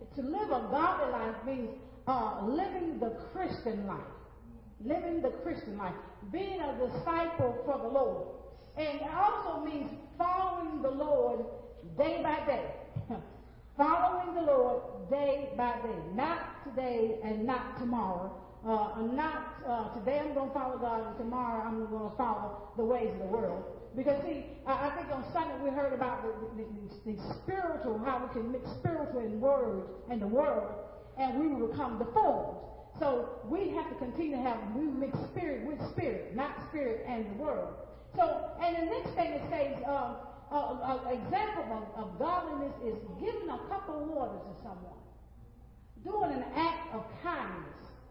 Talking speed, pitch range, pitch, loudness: 170 wpm, 235-325 Hz, 270 Hz, -35 LUFS